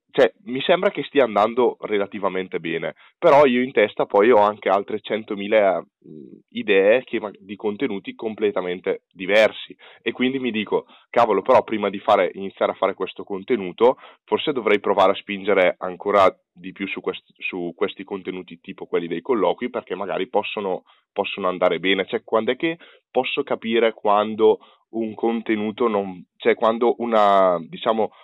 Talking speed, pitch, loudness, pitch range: 155 wpm, 110 Hz, -21 LUFS, 95-125 Hz